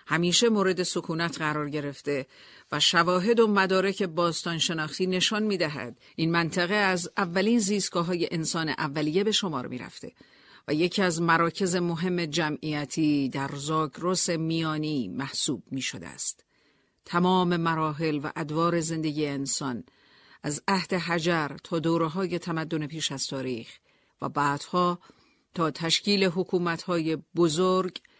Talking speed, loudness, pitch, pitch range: 130 wpm, -26 LUFS, 170 Hz, 155-185 Hz